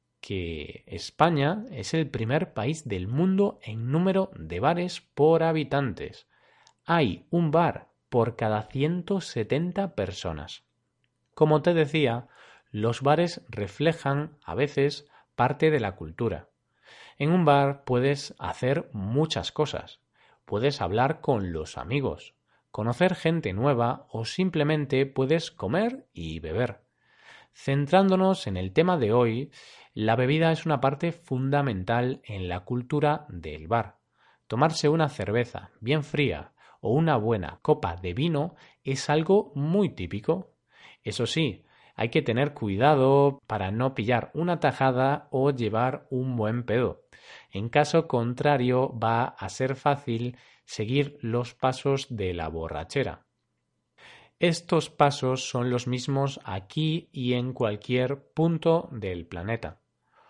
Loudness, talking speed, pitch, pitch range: -27 LUFS, 125 wpm, 135 Hz, 115-155 Hz